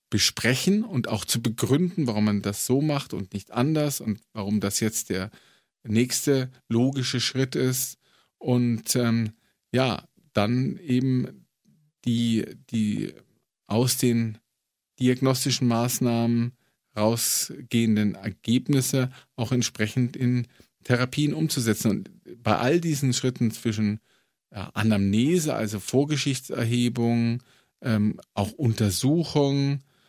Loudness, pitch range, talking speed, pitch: -25 LUFS, 110-130 Hz, 105 wpm, 120 Hz